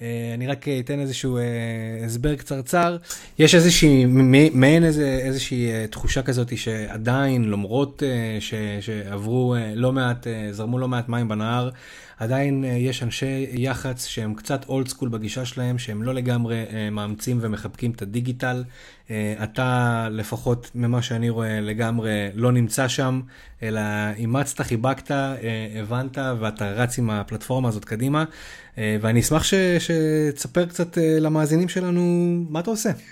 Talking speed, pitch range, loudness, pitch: 140 wpm, 115-140 Hz, -22 LUFS, 125 Hz